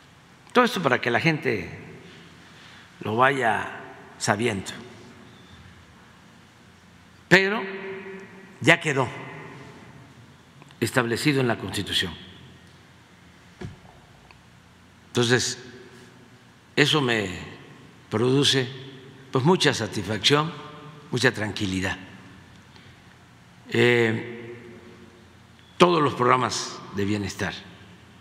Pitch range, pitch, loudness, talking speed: 110-145 Hz, 125 Hz, -23 LUFS, 65 wpm